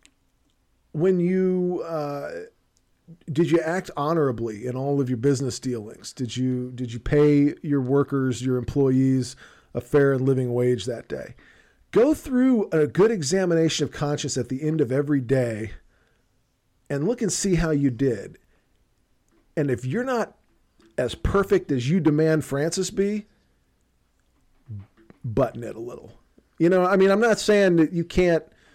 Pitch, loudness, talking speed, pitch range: 145 Hz, -23 LUFS, 155 wpm, 125-175 Hz